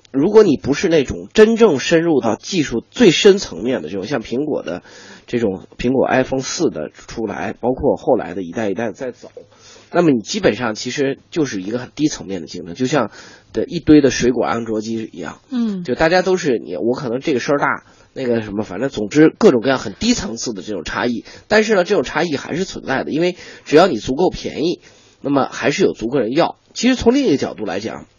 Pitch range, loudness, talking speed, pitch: 115-185 Hz, -17 LUFS, 335 characters per minute, 135 Hz